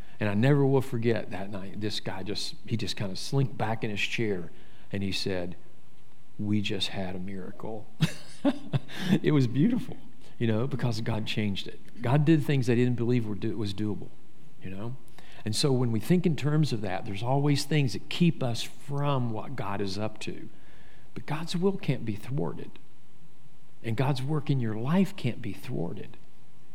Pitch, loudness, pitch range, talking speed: 120 Hz, -29 LUFS, 105-145 Hz, 190 wpm